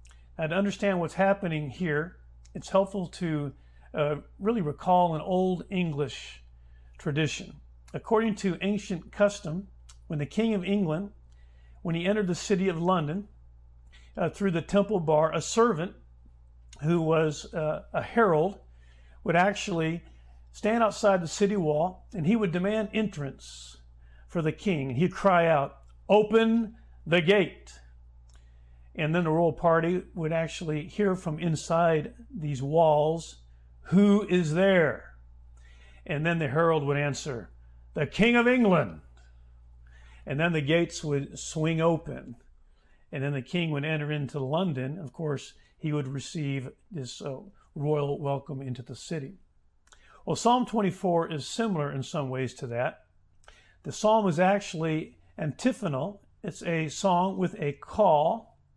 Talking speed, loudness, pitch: 140 wpm, -28 LUFS, 155 Hz